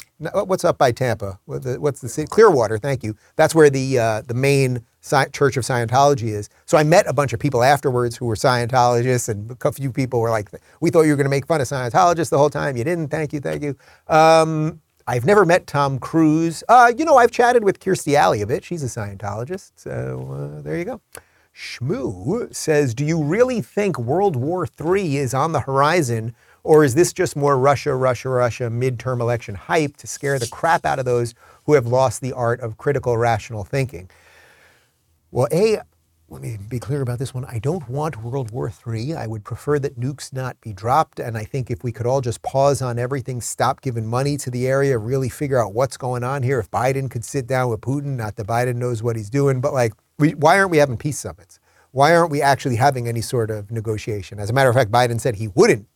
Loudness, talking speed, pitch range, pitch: -19 LUFS, 225 wpm, 115-150 Hz, 130 Hz